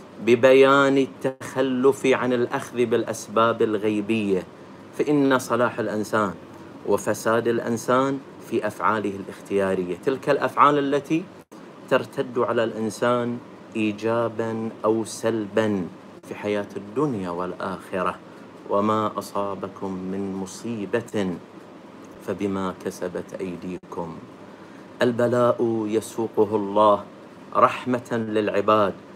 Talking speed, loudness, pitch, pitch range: 80 wpm, -23 LUFS, 115 Hz, 105-120 Hz